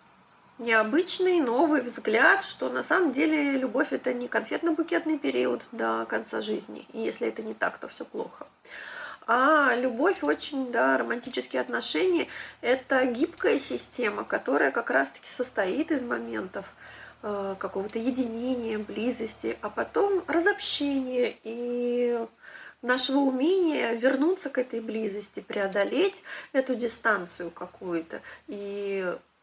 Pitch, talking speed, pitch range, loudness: 250 Hz, 115 wpm, 220-305 Hz, -27 LUFS